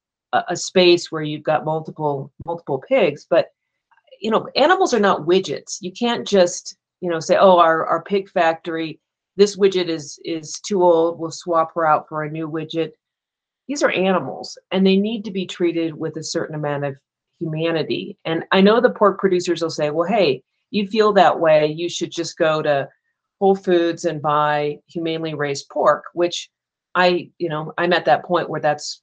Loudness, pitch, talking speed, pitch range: -19 LUFS, 170 Hz, 190 wpm, 155-185 Hz